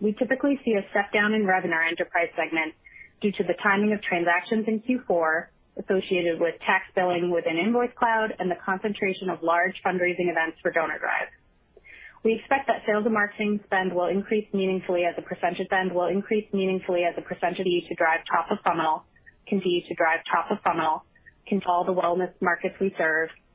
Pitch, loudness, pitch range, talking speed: 185 Hz, -25 LUFS, 175-210 Hz, 195 wpm